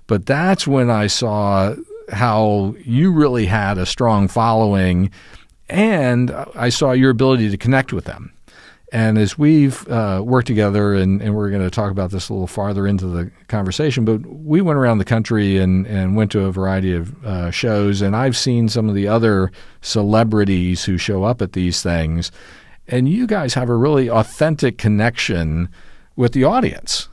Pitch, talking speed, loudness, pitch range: 105 Hz, 180 wpm, -17 LUFS, 95-125 Hz